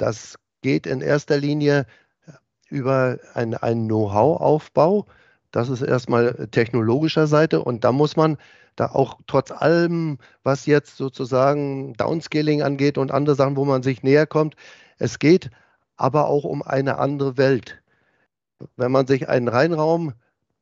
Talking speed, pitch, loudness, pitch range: 140 wpm, 140 Hz, -20 LUFS, 130-150 Hz